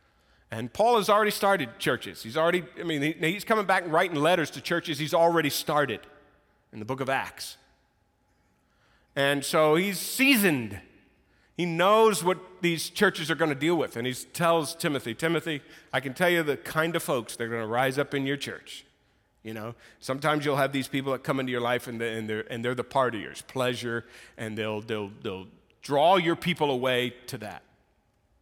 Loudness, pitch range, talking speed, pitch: -26 LUFS, 120-170 Hz, 195 wpm, 140 Hz